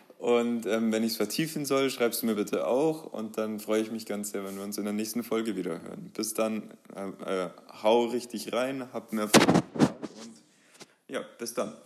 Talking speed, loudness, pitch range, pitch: 210 wpm, -29 LUFS, 105-120 Hz, 110 Hz